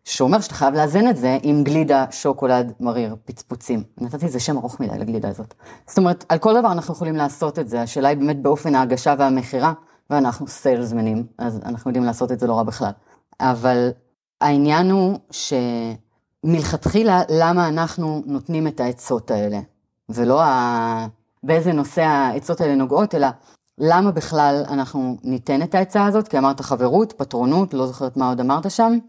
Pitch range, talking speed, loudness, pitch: 125-160 Hz, 165 wpm, -19 LUFS, 140 Hz